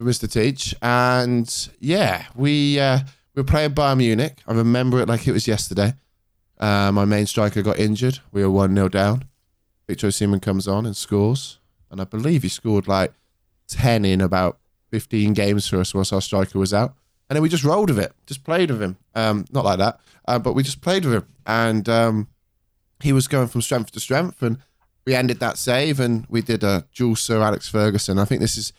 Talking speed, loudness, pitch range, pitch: 210 wpm, -20 LUFS, 100-130 Hz, 110 Hz